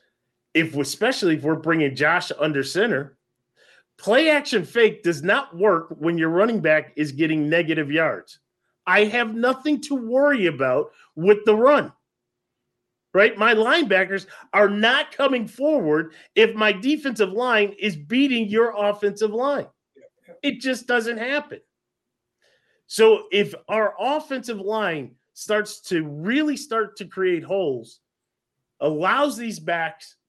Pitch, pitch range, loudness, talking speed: 210 Hz, 170-260 Hz, -21 LUFS, 130 wpm